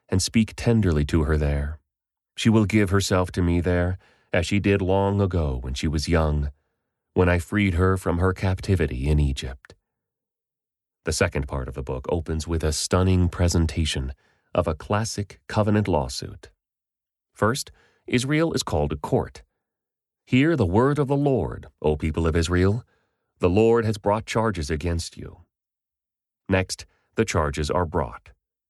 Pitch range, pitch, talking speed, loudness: 80-105 Hz, 90 Hz, 155 wpm, -23 LUFS